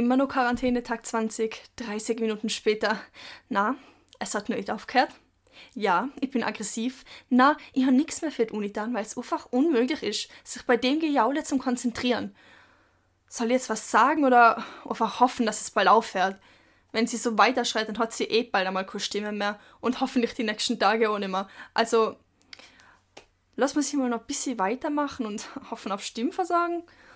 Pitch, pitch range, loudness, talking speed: 240 Hz, 220-265 Hz, -26 LUFS, 185 wpm